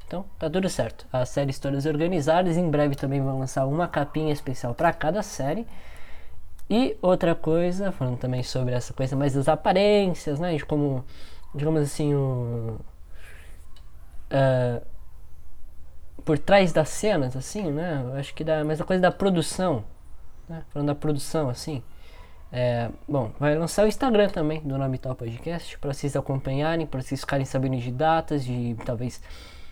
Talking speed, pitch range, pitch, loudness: 160 wpm, 125-160 Hz, 140 Hz, -25 LUFS